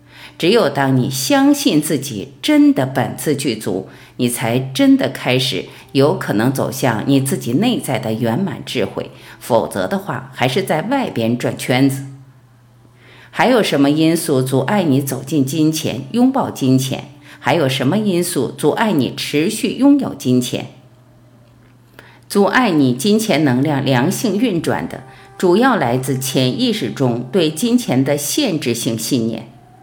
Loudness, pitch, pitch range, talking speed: -16 LUFS, 135 Hz, 125-160 Hz, 215 characters per minute